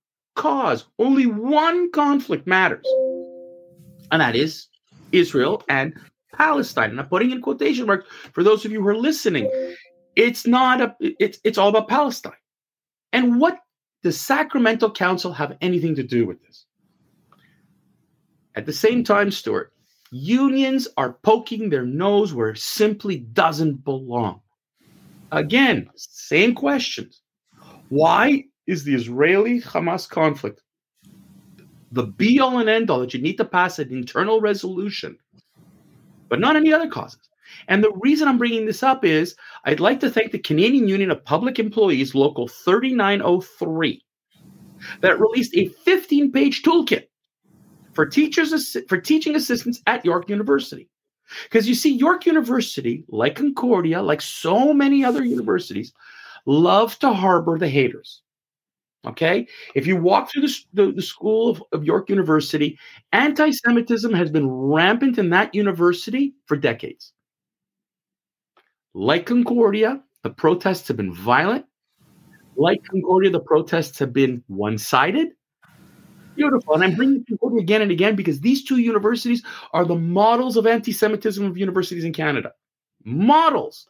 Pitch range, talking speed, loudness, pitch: 170-260 Hz, 140 wpm, -19 LUFS, 215 Hz